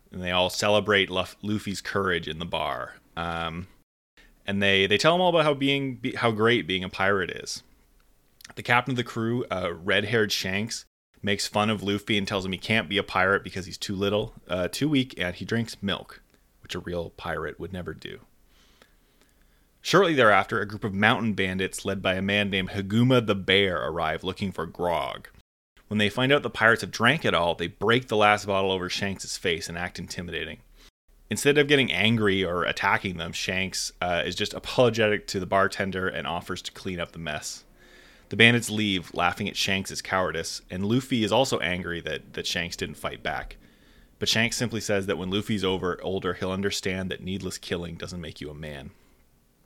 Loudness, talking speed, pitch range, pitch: -25 LUFS, 195 wpm, 90-110 Hz, 100 Hz